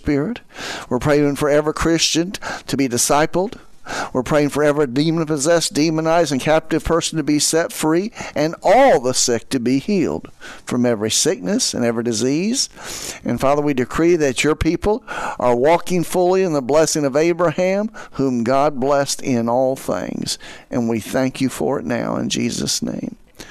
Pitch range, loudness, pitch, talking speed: 130-165 Hz, -18 LUFS, 150 Hz, 170 wpm